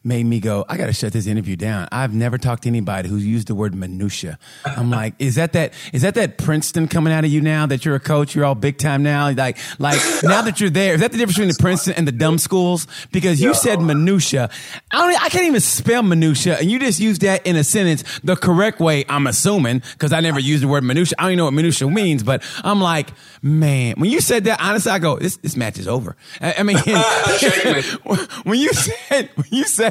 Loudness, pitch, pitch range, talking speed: -17 LUFS, 155 Hz, 130-185 Hz, 245 wpm